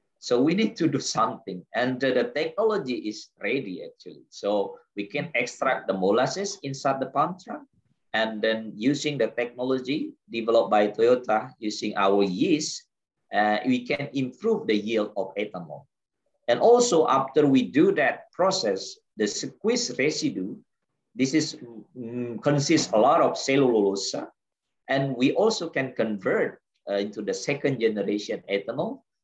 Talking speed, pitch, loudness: 145 wpm, 130 Hz, -25 LUFS